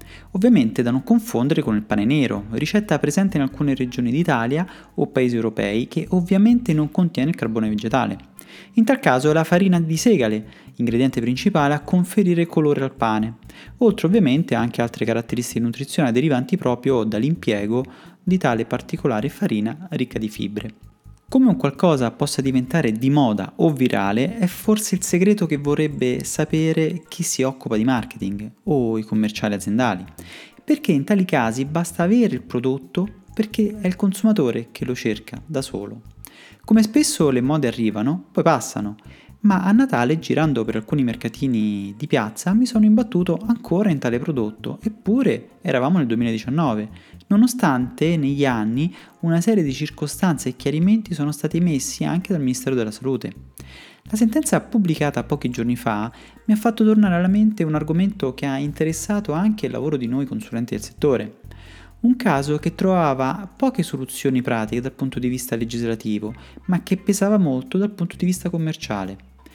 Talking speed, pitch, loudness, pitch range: 160 wpm, 145 Hz, -20 LUFS, 120-185 Hz